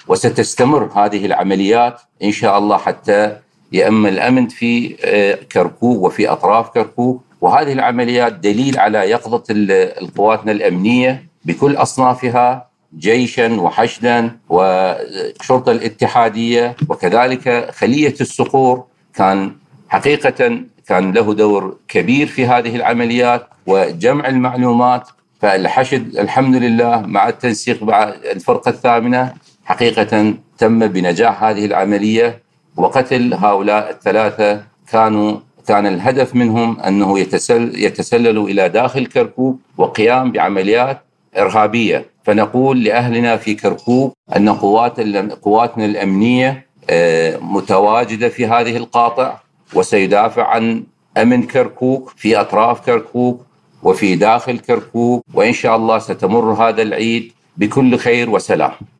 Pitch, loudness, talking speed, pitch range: 120 Hz, -14 LUFS, 105 wpm, 105-125 Hz